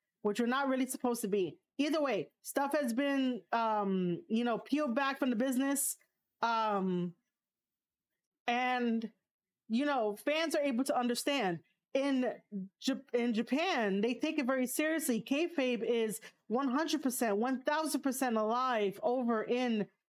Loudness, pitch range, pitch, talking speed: -34 LUFS, 220-275 Hz, 250 Hz, 145 wpm